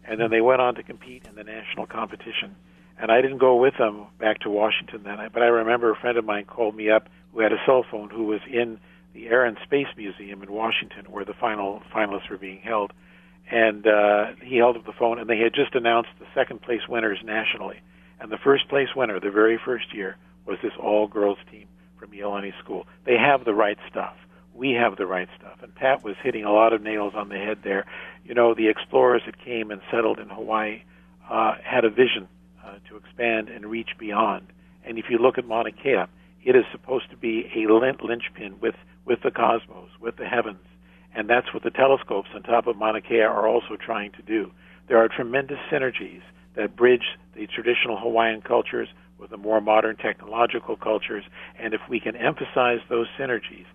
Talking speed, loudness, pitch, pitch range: 210 wpm, -23 LUFS, 110 Hz, 100-115 Hz